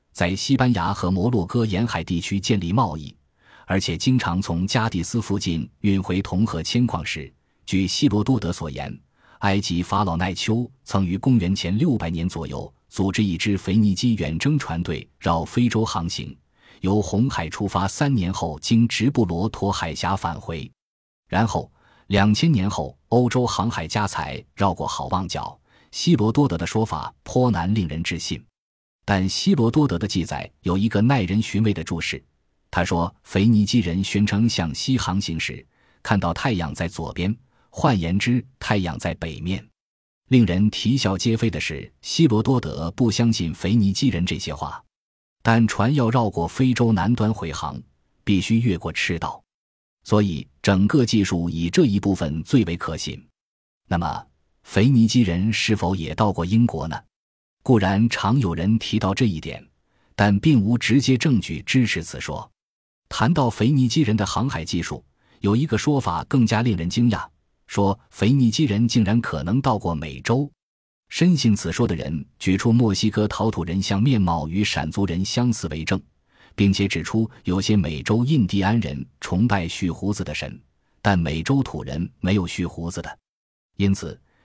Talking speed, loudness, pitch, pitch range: 245 characters per minute, -22 LUFS, 100 Hz, 85-115 Hz